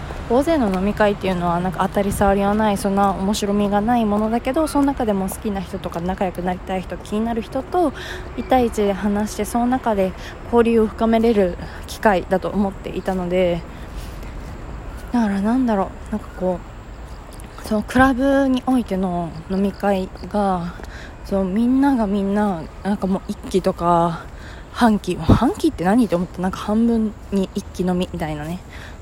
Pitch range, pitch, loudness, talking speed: 185-225 Hz, 200 Hz, -20 LUFS, 315 characters per minute